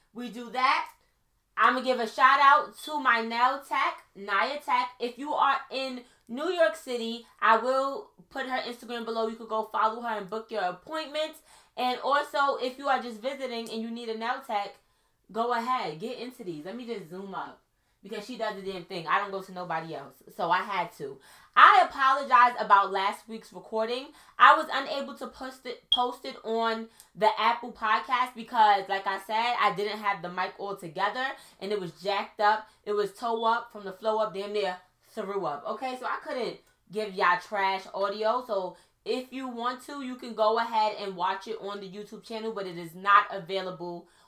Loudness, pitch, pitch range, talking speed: -27 LUFS, 225 Hz, 200-255 Hz, 205 wpm